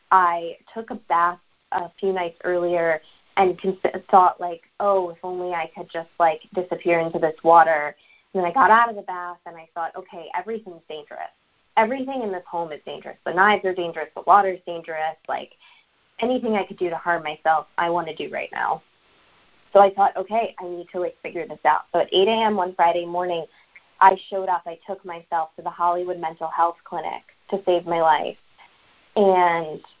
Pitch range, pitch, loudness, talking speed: 170-190 Hz, 175 Hz, -22 LUFS, 195 wpm